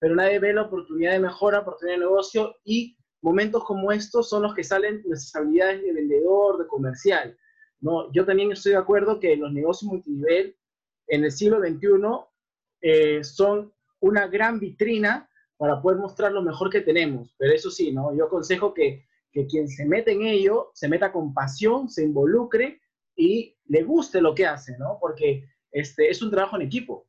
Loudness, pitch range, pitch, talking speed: -23 LUFS, 155-215 Hz, 195 Hz, 180 wpm